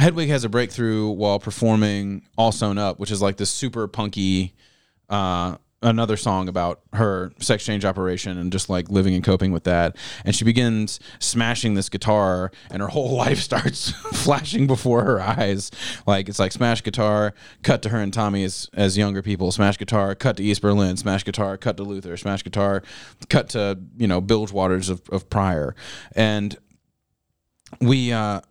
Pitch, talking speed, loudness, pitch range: 100 Hz, 180 wpm, -22 LUFS, 95-115 Hz